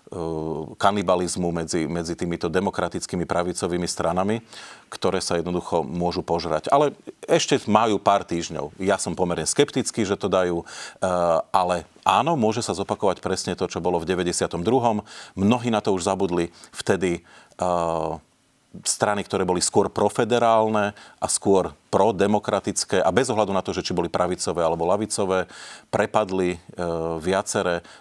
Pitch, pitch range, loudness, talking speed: 90 Hz, 85-100 Hz, -23 LUFS, 135 wpm